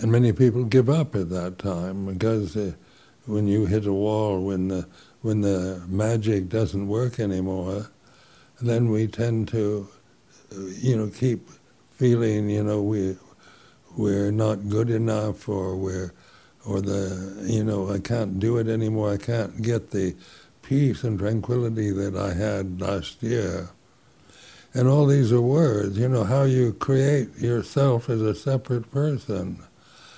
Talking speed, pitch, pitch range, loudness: 150 wpm, 110 Hz, 100-120 Hz, -24 LUFS